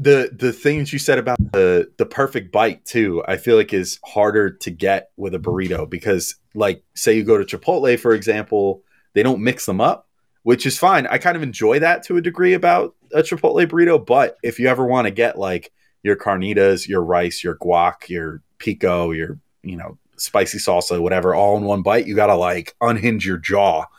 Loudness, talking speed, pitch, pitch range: -18 LUFS, 205 wpm, 120 Hz, 100-155 Hz